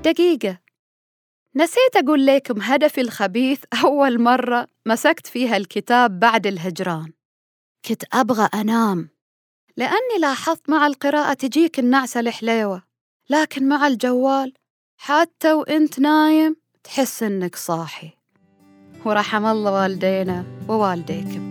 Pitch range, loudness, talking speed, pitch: 195-290 Hz, -19 LUFS, 100 wpm, 240 Hz